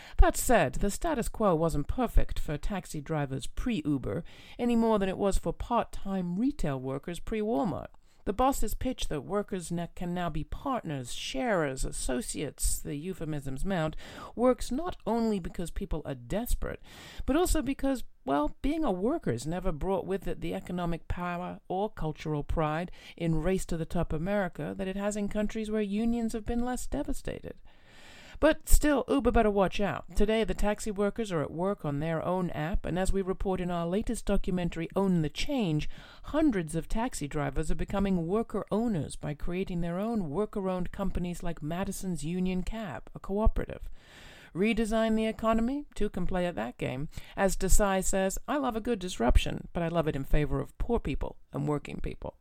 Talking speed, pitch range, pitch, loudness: 175 wpm, 165-225 Hz, 190 Hz, -31 LUFS